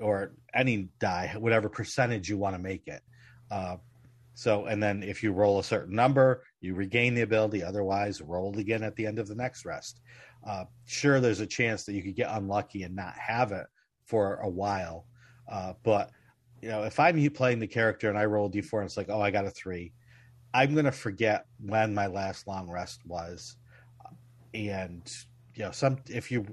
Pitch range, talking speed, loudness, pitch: 100-120 Hz, 200 wpm, -30 LUFS, 110 Hz